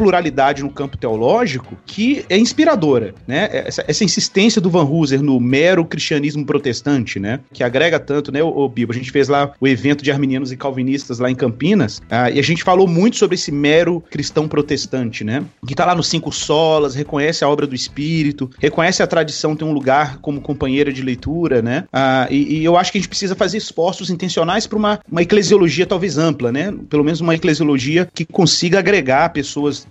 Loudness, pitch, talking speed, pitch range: -16 LUFS, 150 Hz, 200 wpm, 135-175 Hz